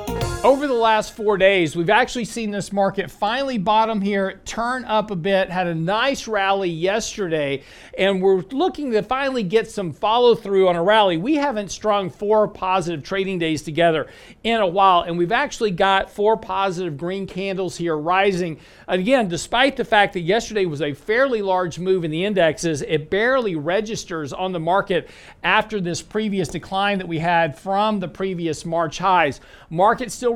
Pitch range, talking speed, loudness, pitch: 175-215 Hz, 175 wpm, -20 LUFS, 195 Hz